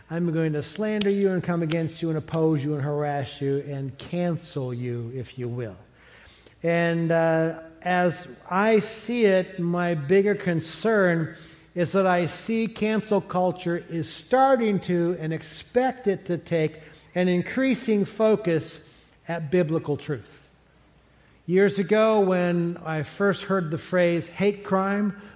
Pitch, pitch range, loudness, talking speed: 170 Hz, 160-195 Hz, -25 LUFS, 140 wpm